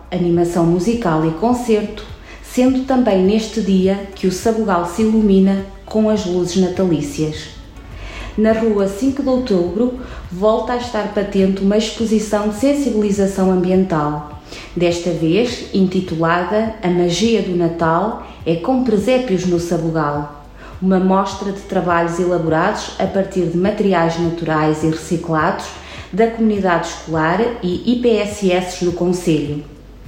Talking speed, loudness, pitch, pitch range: 125 wpm, -17 LUFS, 190 Hz, 170-215 Hz